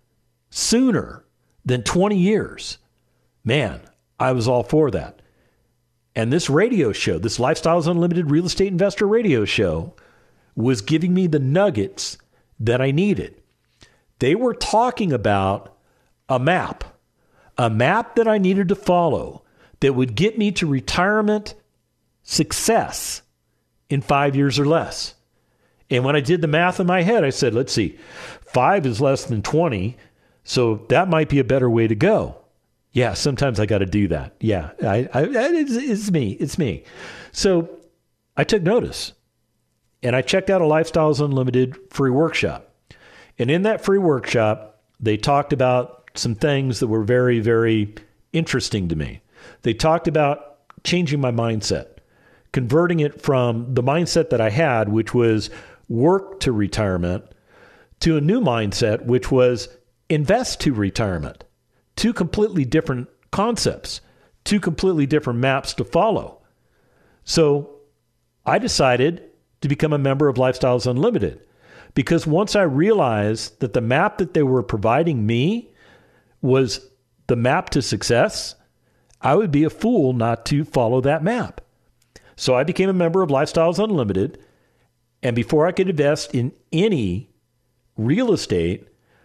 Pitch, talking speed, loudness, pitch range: 135 Hz, 145 wpm, -20 LUFS, 120-170 Hz